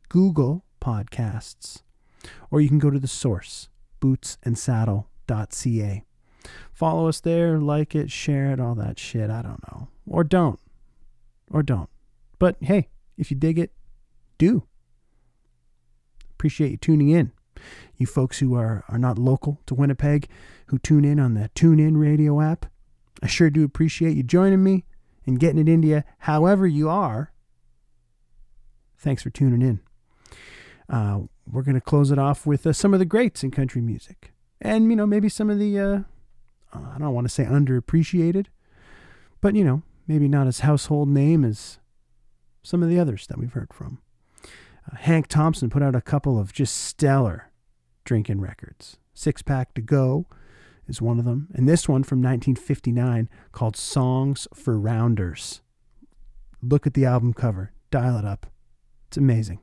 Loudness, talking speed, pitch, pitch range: -22 LUFS, 160 wpm, 135 Hz, 115-155 Hz